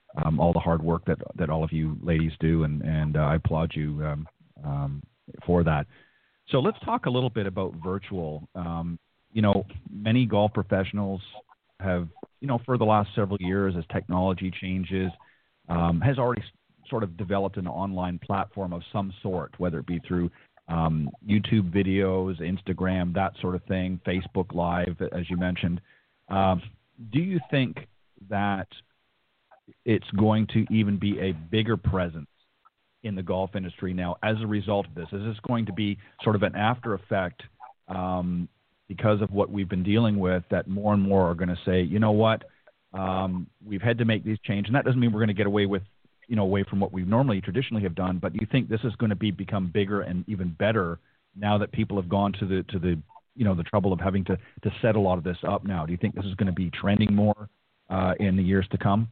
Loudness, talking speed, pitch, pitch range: -27 LUFS, 215 wpm, 95 Hz, 90-105 Hz